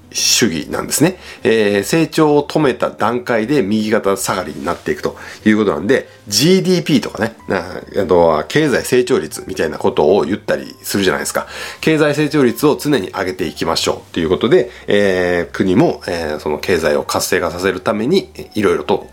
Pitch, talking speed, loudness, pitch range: 115 Hz, 375 characters per minute, -16 LUFS, 100-150 Hz